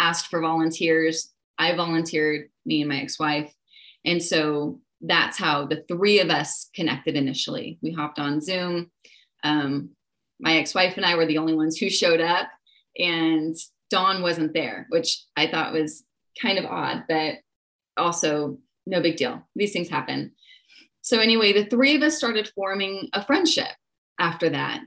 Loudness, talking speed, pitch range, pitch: -23 LUFS, 165 wpm, 155-190 Hz, 165 Hz